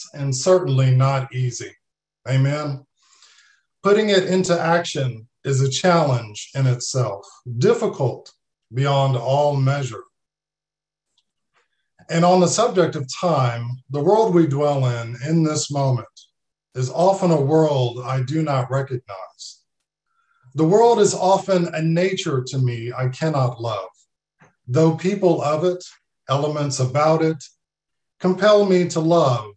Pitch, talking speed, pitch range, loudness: 145 Hz, 125 wpm, 130-175 Hz, -19 LUFS